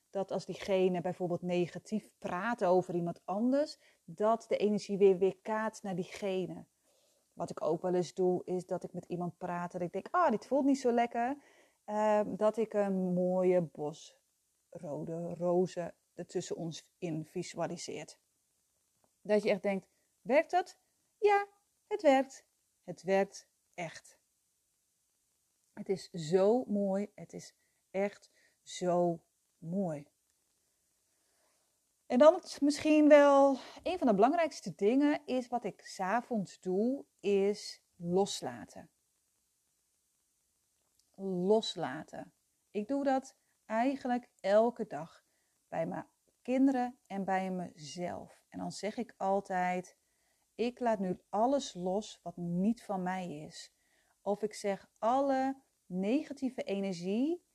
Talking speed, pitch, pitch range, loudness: 130 wpm, 195 Hz, 180-240 Hz, -33 LUFS